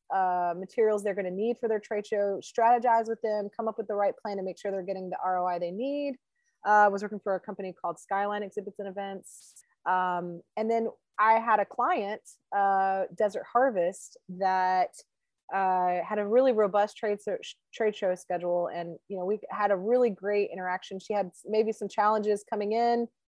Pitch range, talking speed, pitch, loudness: 190-220 Hz, 200 wpm, 205 Hz, -29 LUFS